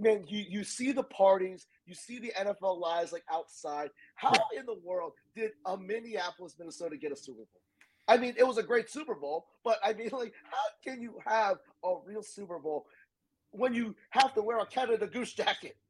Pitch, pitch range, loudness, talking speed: 210 Hz, 175-240 Hz, -33 LUFS, 205 wpm